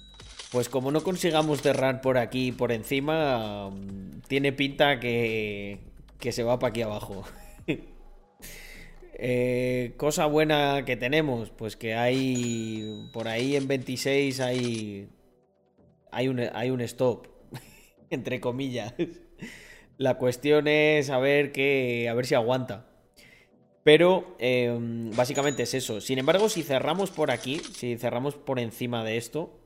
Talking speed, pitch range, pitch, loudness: 130 wpm, 120-140 Hz, 125 Hz, -27 LUFS